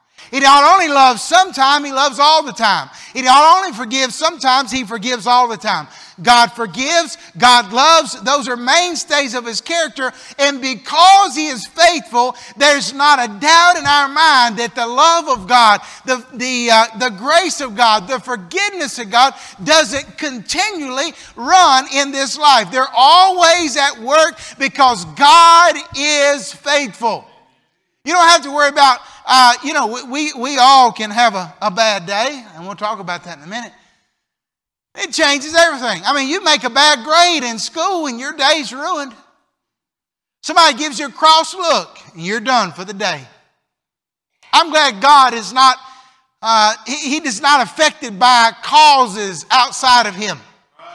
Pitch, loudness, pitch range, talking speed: 270 Hz, -12 LUFS, 240-310 Hz, 165 wpm